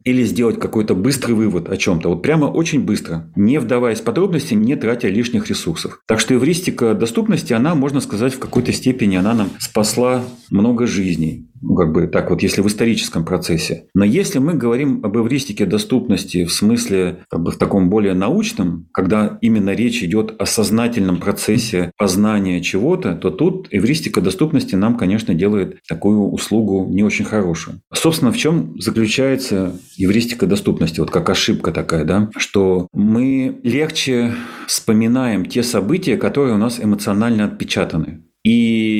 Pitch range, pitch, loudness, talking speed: 95-125 Hz, 110 Hz, -17 LUFS, 155 wpm